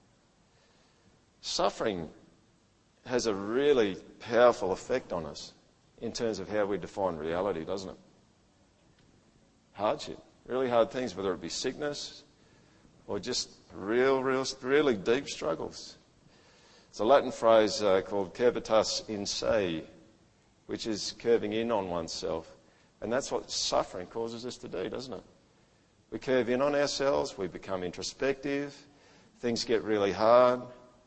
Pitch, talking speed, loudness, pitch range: 120 Hz, 135 wpm, -30 LUFS, 105-135 Hz